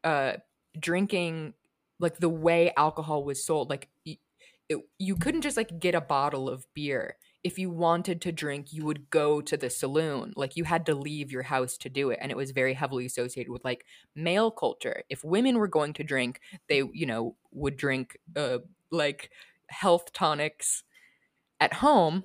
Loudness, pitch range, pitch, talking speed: -29 LUFS, 135-175 Hz, 155 Hz, 185 wpm